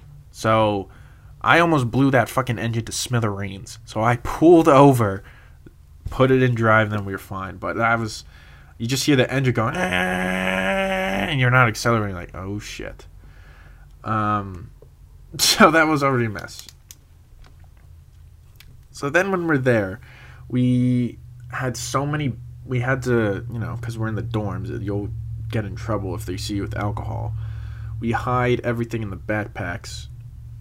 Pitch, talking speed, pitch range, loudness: 110 Hz, 160 wpm, 100-125 Hz, -21 LUFS